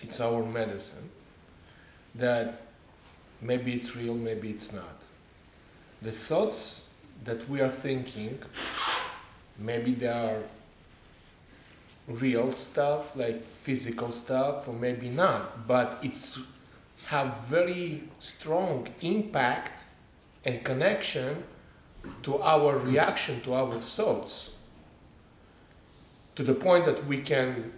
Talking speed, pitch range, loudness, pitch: 100 wpm, 110-135 Hz, -30 LUFS, 120 Hz